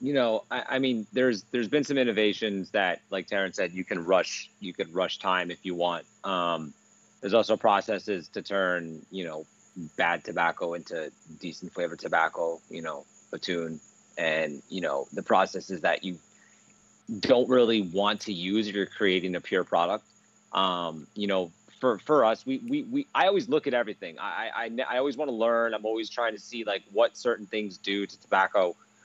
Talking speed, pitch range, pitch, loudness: 190 wpm, 90-120 Hz, 105 Hz, -28 LUFS